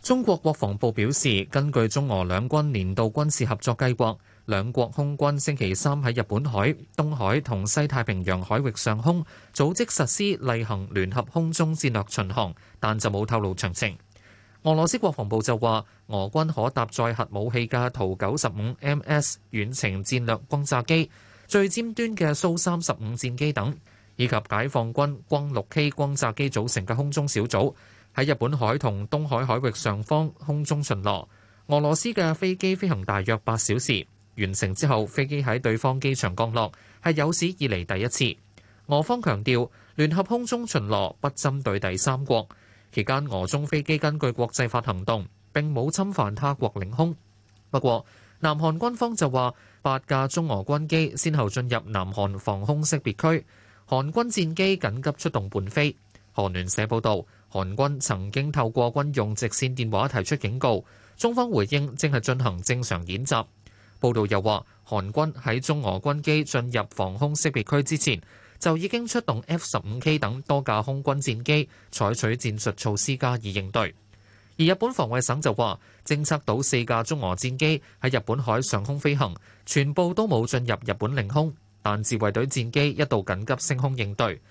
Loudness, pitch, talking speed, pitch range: -25 LUFS, 125 Hz, 255 characters per minute, 105-145 Hz